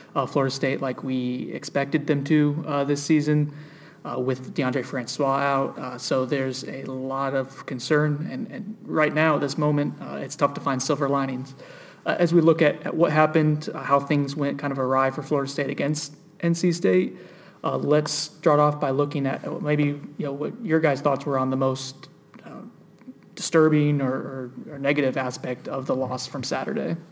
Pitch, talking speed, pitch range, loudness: 145 Hz, 195 wpm, 135-155 Hz, -24 LUFS